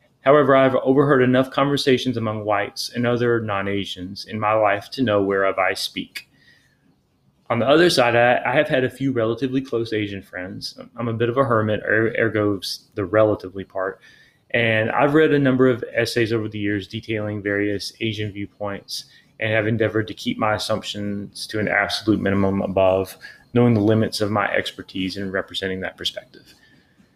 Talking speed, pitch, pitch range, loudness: 175 wpm, 110 Hz, 100-125 Hz, -21 LUFS